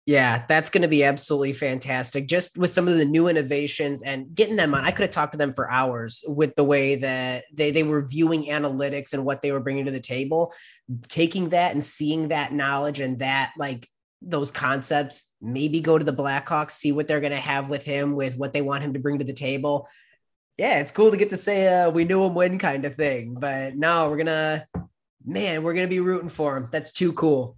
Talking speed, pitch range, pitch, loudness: 235 wpm, 140-160 Hz, 145 Hz, -23 LUFS